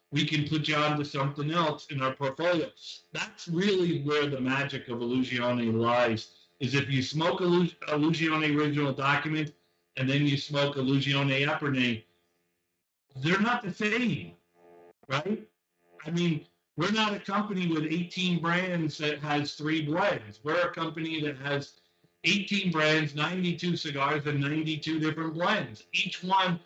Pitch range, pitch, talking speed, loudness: 130-170 Hz, 150 Hz, 150 wpm, -29 LUFS